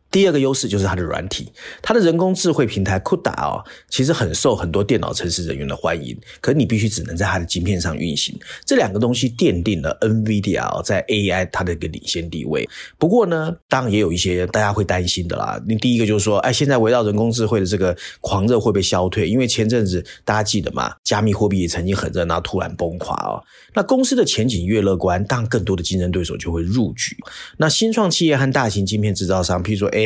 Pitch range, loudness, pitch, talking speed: 90-125 Hz, -19 LUFS, 105 Hz, 370 characters per minute